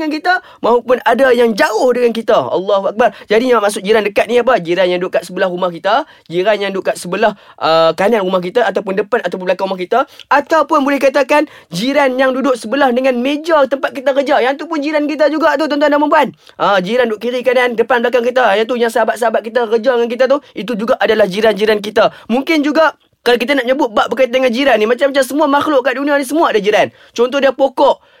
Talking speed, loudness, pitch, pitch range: 225 wpm, -13 LUFS, 250 Hz, 220-280 Hz